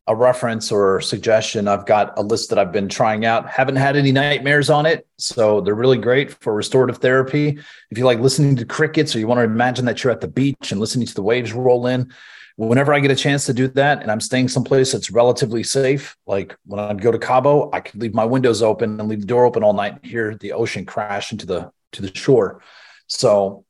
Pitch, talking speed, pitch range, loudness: 125 Hz, 240 wpm, 110-135 Hz, -18 LUFS